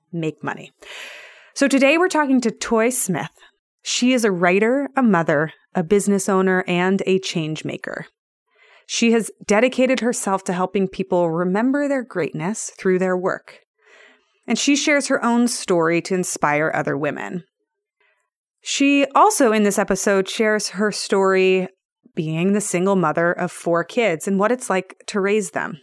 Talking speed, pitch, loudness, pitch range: 155 wpm, 200 Hz, -19 LUFS, 185-245 Hz